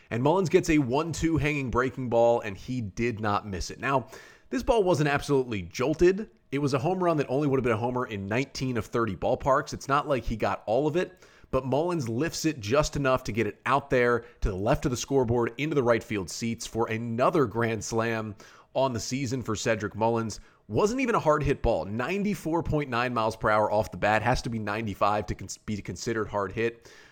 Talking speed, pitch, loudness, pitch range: 225 wpm, 120 Hz, -27 LUFS, 110-140 Hz